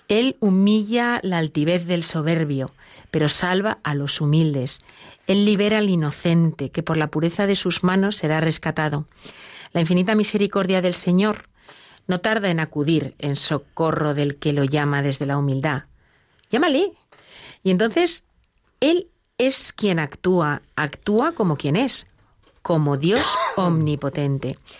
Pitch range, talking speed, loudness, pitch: 150-200 Hz, 135 wpm, -21 LUFS, 165 Hz